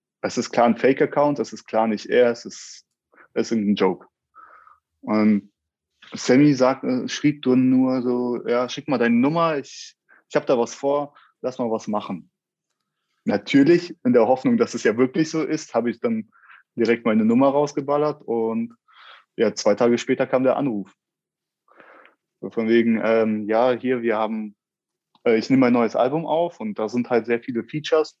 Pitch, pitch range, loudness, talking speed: 125 Hz, 115-150 Hz, -21 LUFS, 175 wpm